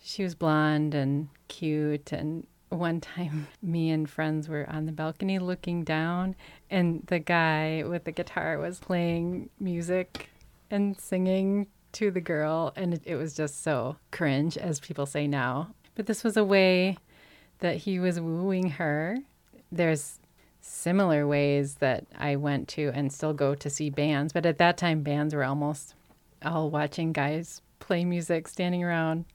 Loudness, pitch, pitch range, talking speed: -29 LUFS, 160 Hz, 150-180 Hz, 160 wpm